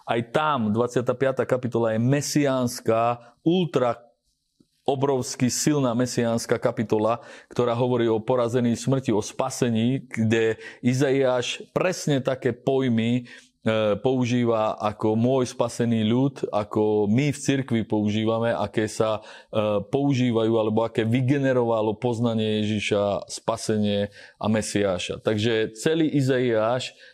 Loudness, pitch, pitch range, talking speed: -24 LUFS, 120 Hz, 110-130 Hz, 110 wpm